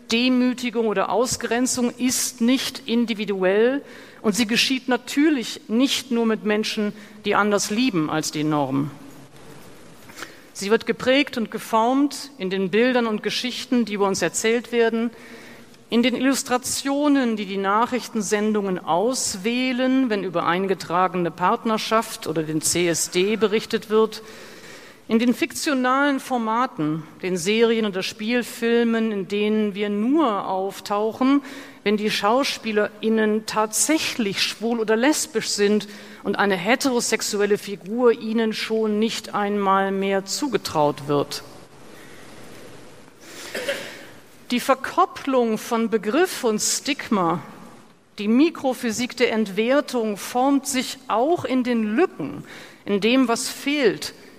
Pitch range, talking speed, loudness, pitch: 205-250 Hz, 115 wpm, -22 LUFS, 225 Hz